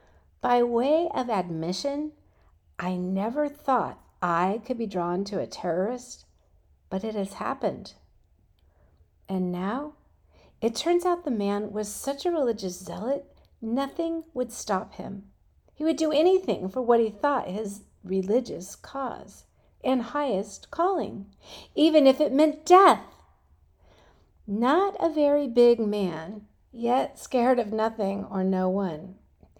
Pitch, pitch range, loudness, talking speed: 215 Hz, 180-280 Hz, -26 LUFS, 130 wpm